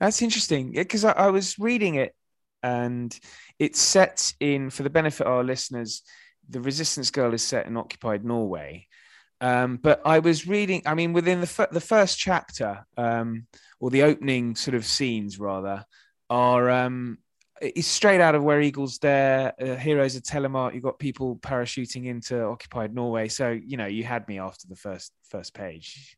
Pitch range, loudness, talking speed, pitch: 120-150 Hz, -24 LUFS, 180 wpm, 130 Hz